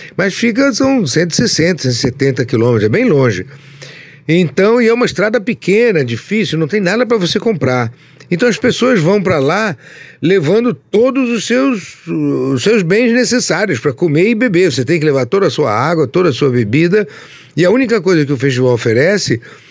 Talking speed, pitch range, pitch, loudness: 185 wpm, 140-225 Hz, 170 Hz, -13 LUFS